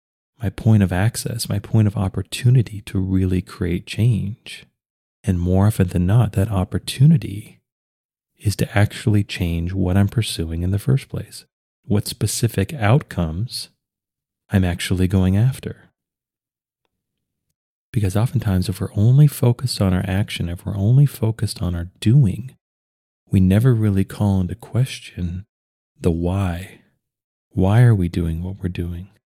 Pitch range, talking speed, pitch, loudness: 90-115 Hz, 140 wpm, 100 Hz, -20 LUFS